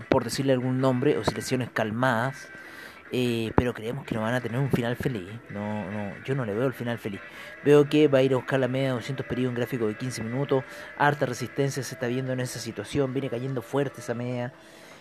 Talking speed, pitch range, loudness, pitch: 230 wpm, 120-135 Hz, -27 LUFS, 125 Hz